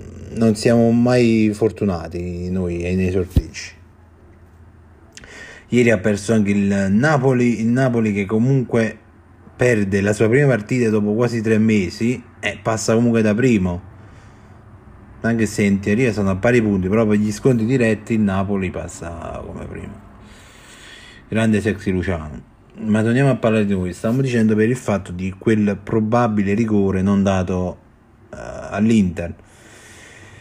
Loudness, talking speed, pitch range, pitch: -18 LUFS, 140 wpm, 95-115 Hz, 105 Hz